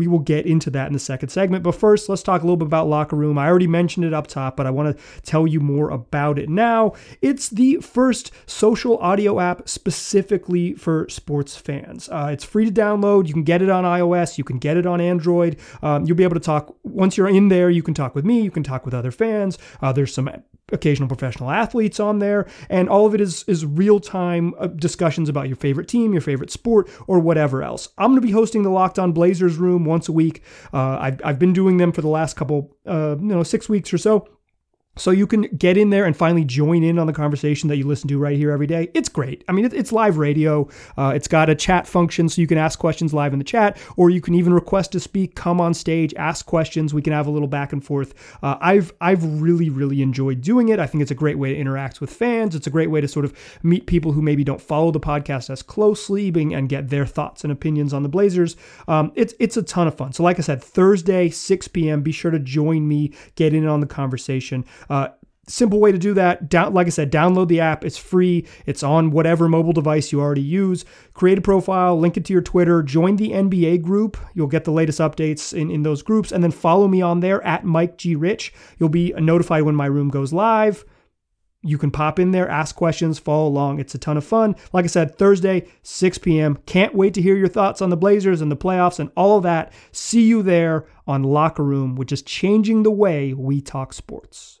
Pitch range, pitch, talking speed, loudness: 150-190 Hz, 165 Hz, 245 wpm, -19 LUFS